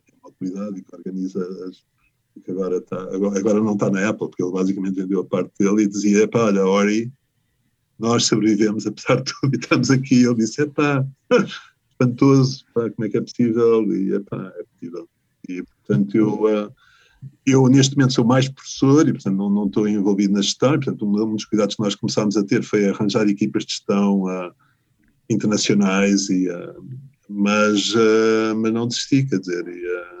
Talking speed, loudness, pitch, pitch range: 180 wpm, -19 LUFS, 110 Hz, 100-125 Hz